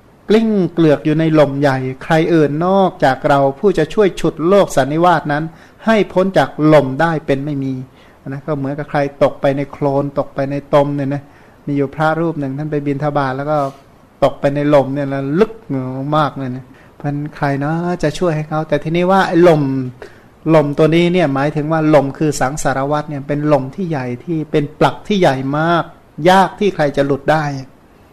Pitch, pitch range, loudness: 150 Hz, 140-160 Hz, -15 LUFS